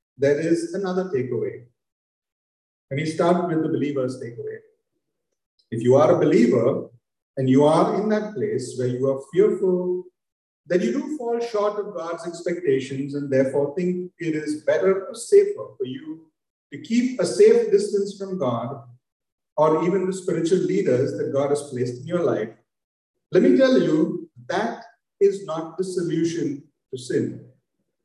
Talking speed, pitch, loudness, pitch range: 160 wpm, 170 Hz, -22 LUFS, 135-200 Hz